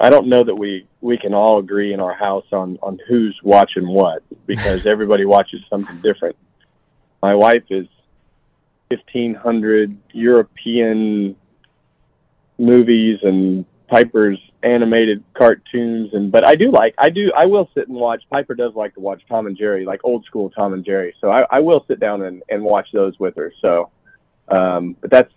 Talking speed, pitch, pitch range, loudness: 175 wpm, 105 Hz, 95-115 Hz, -16 LUFS